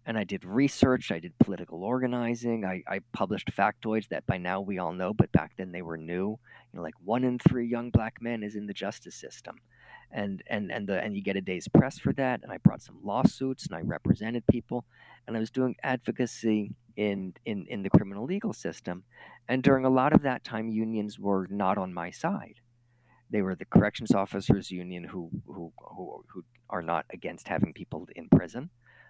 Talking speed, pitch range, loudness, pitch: 210 wpm, 95-120 Hz, -29 LUFS, 110 Hz